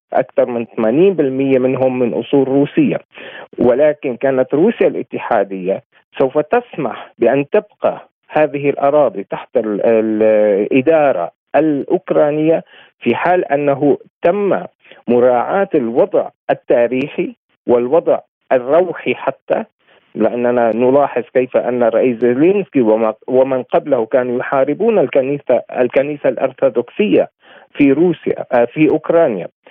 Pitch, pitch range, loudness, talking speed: 135 Hz, 120-150 Hz, -15 LUFS, 95 wpm